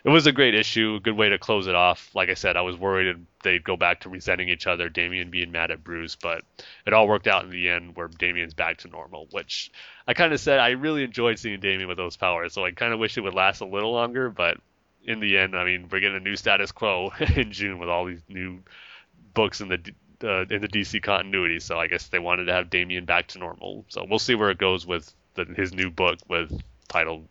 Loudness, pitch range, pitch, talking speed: -24 LUFS, 90-110 Hz, 95 Hz, 255 wpm